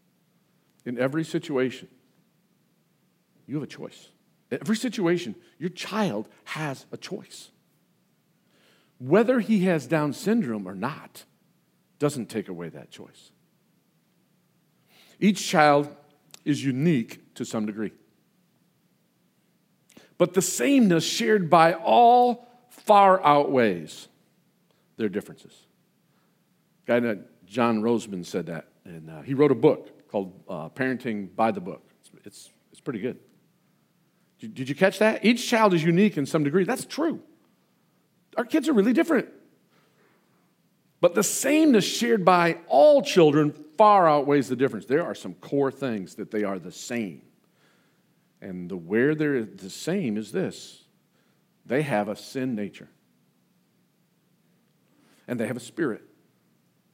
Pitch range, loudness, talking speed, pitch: 135-195 Hz, -24 LUFS, 135 wpm, 170 Hz